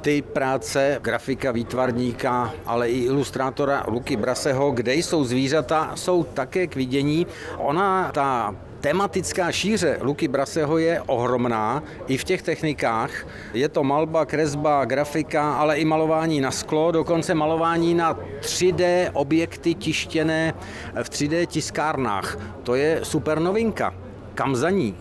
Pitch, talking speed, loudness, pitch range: 150 Hz, 130 wpm, -23 LUFS, 130-165 Hz